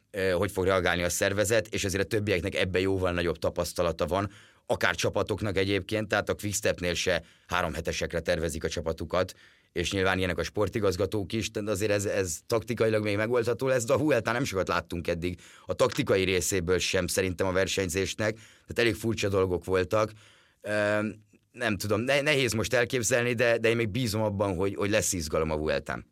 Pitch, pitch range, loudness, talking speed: 100 Hz, 95-110 Hz, -28 LUFS, 180 wpm